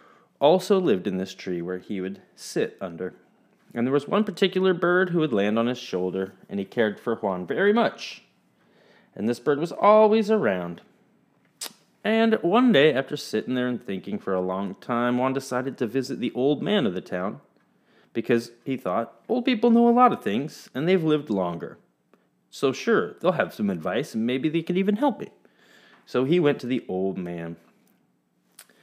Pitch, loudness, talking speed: 125 Hz, -24 LUFS, 190 wpm